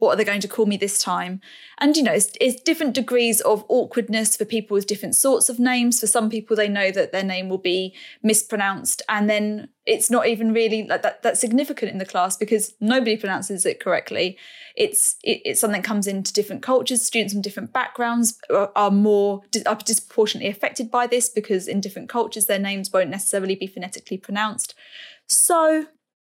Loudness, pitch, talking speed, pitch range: -21 LUFS, 220 Hz, 200 wpm, 200-245 Hz